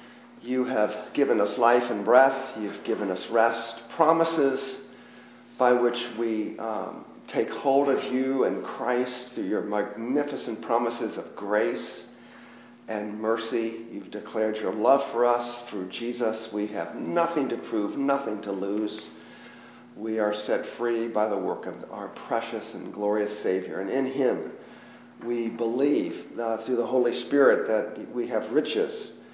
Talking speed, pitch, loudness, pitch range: 150 wpm, 115 Hz, -27 LUFS, 105-130 Hz